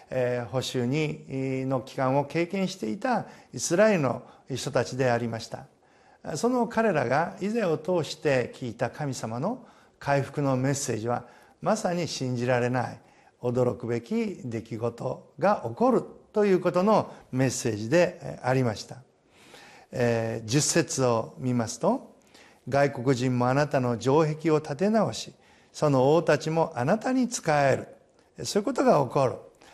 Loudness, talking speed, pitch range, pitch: -27 LUFS, 275 characters per minute, 125-170 Hz, 135 Hz